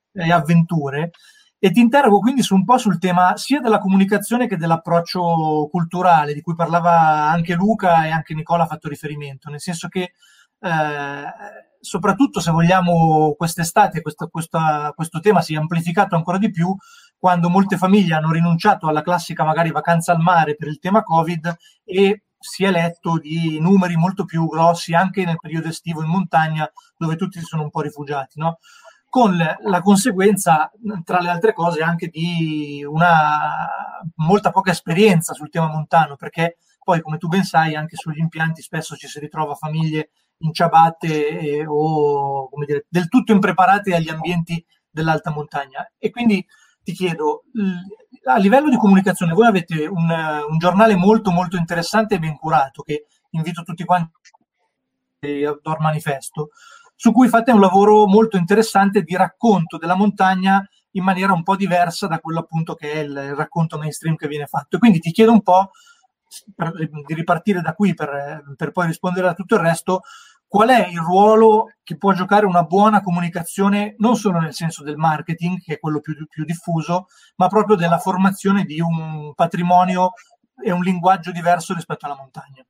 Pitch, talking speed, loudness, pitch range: 170 Hz, 170 wpm, -18 LUFS, 160-195 Hz